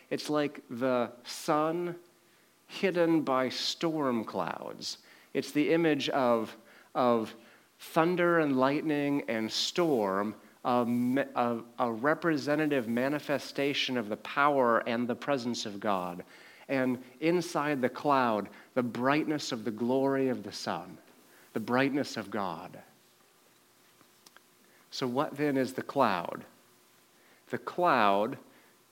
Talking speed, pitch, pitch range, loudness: 115 wpm, 130 Hz, 115-150 Hz, -30 LUFS